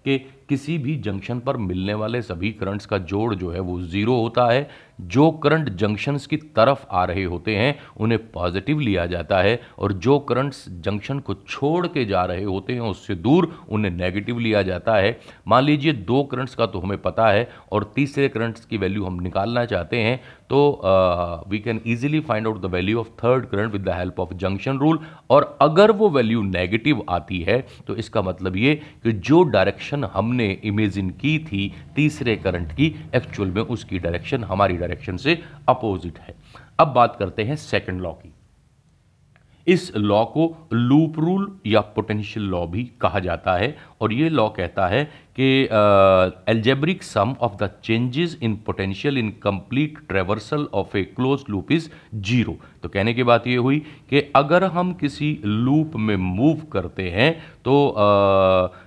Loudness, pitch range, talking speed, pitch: -21 LUFS, 100-140 Hz, 175 wpm, 115 Hz